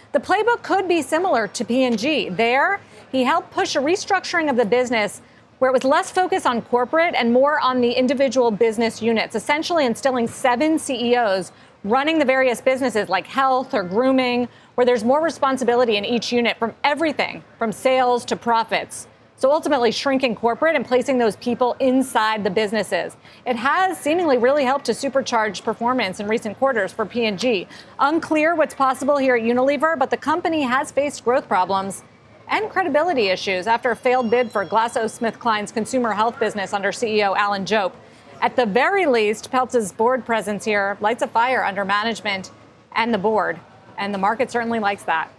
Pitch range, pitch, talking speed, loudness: 225-275 Hz, 245 Hz, 170 wpm, -20 LUFS